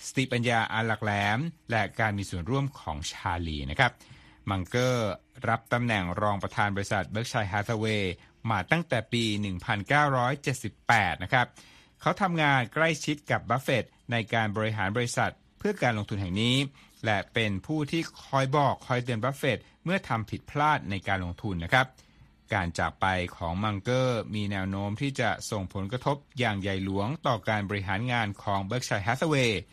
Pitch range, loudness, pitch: 100-130 Hz, -28 LUFS, 110 Hz